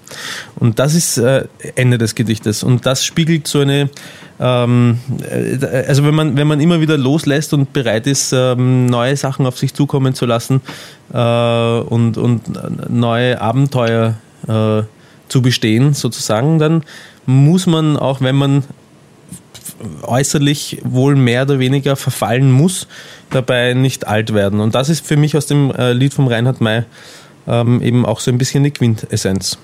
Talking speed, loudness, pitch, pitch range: 145 wpm, -14 LUFS, 130 Hz, 120-145 Hz